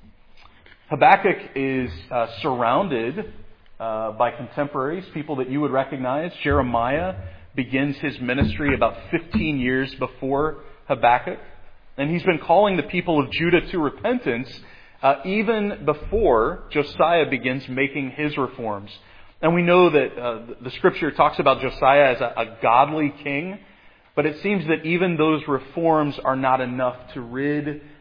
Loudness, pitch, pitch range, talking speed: -21 LUFS, 140 Hz, 125-155 Hz, 140 wpm